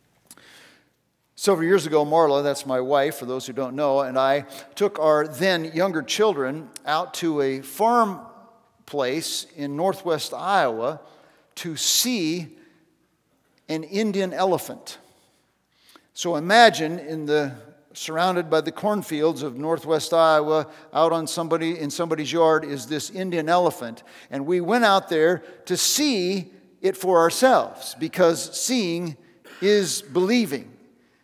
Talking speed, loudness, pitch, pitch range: 130 wpm, -22 LUFS, 165 Hz, 150-185 Hz